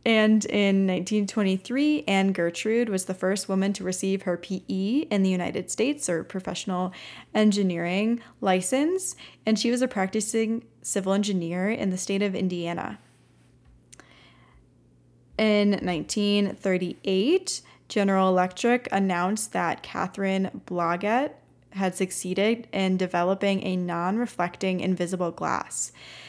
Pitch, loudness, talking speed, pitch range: 195 Hz, -26 LUFS, 110 wpm, 180-210 Hz